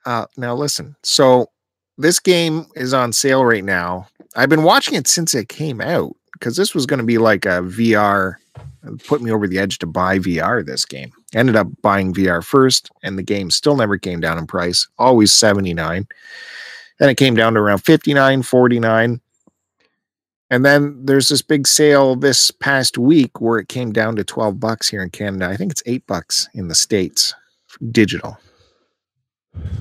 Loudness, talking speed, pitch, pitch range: -15 LUFS, 185 wpm, 115 Hz, 100-140 Hz